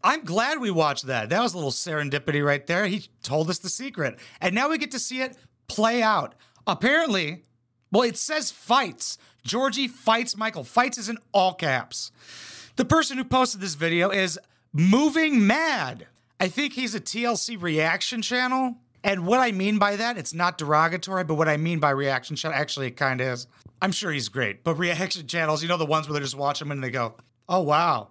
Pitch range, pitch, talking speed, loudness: 150-235 Hz, 185 Hz, 205 wpm, -24 LUFS